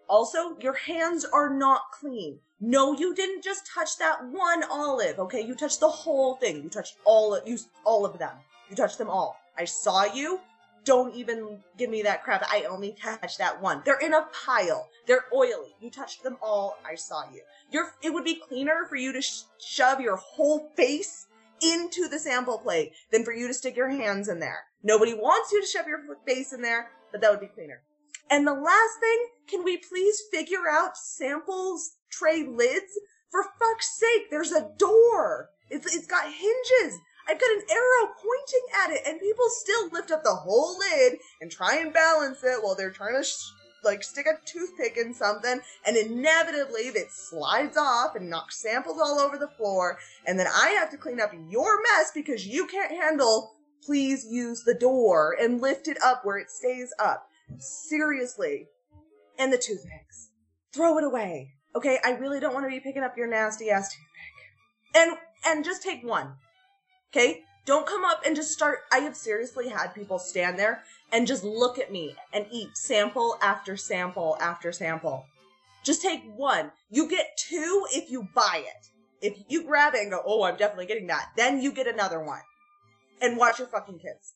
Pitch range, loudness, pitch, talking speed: 215-330 Hz, -26 LUFS, 270 Hz, 195 wpm